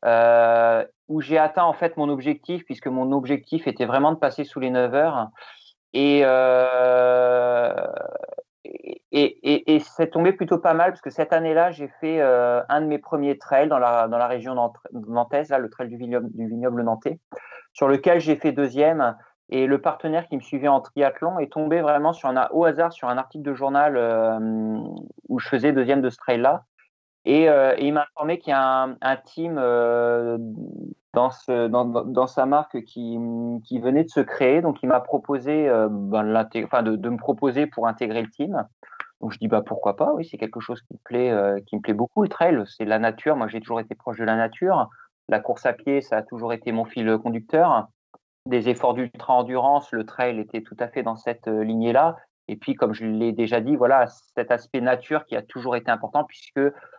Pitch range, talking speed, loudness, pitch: 120-150 Hz, 210 wpm, -22 LUFS, 130 Hz